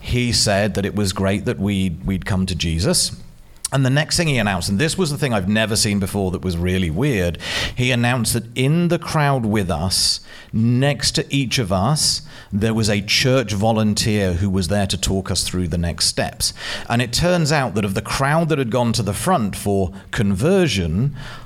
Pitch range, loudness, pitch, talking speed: 95-130 Hz, -19 LUFS, 105 Hz, 210 wpm